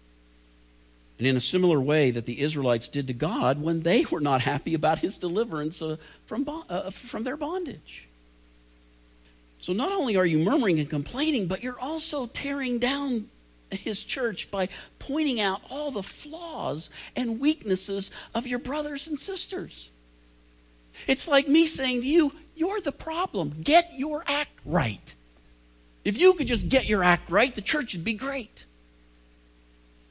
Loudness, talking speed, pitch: -26 LUFS, 160 wpm, 185 Hz